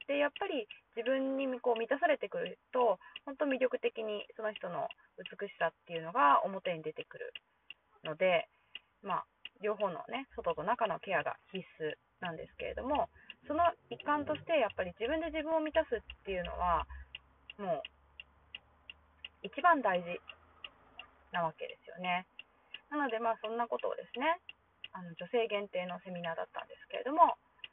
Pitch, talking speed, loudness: 230 Hz, 305 characters per minute, -35 LUFS